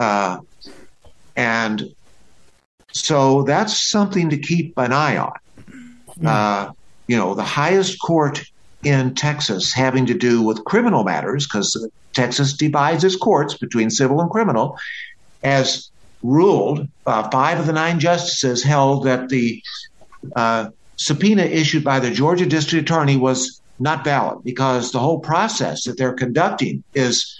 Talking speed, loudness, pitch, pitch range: 140 wpm, -18 LUFS, 135 Hz, 125-160 Hz